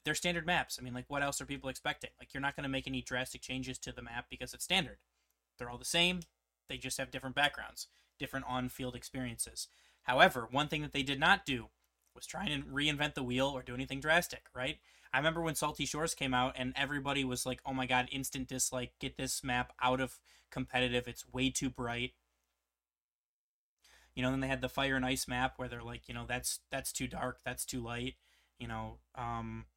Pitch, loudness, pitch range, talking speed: 130 Hz, -36 LUFS, 120-135 Hz, 220 wpm